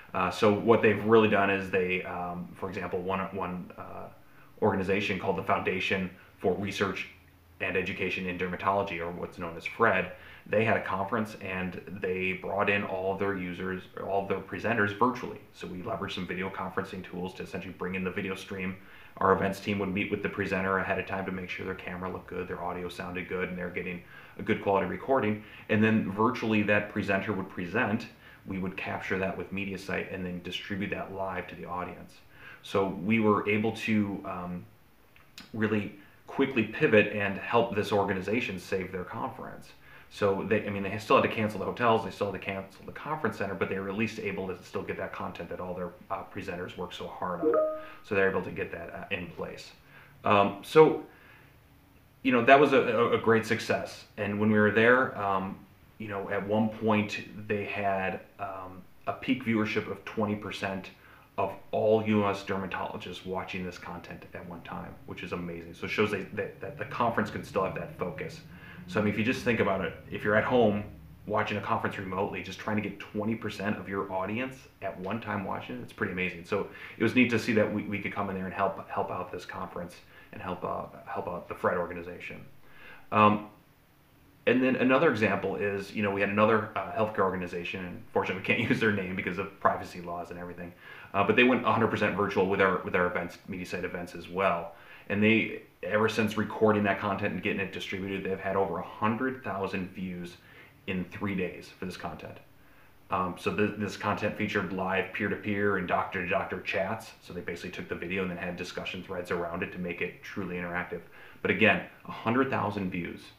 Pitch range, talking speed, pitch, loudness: 95-105 Hz, 205 wpm, 100 Hz, -30 LUFS